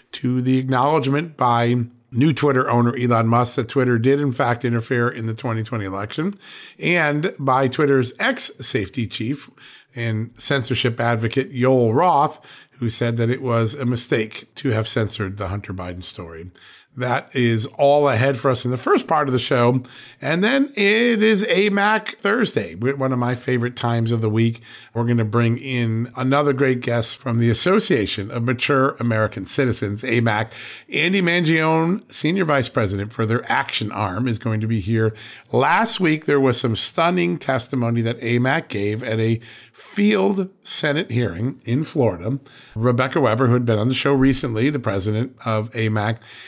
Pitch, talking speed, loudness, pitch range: 125 Hz, 170 wpm, -20 LUFS, 115-140 Hz